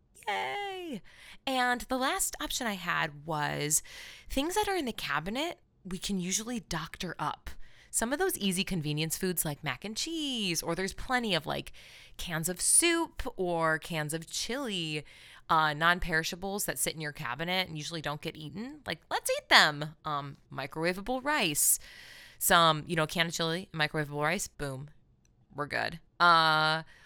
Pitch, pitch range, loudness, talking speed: 170 Hz, 155-220 Hz, -30 LUFS, 160 wpm